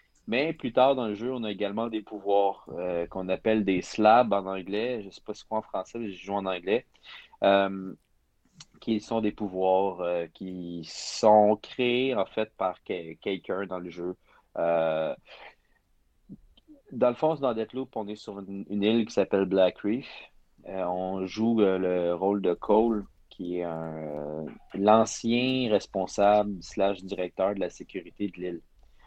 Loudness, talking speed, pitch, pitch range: -28 LUFS, 175 wpm, 100 Hz, 90-110 Hz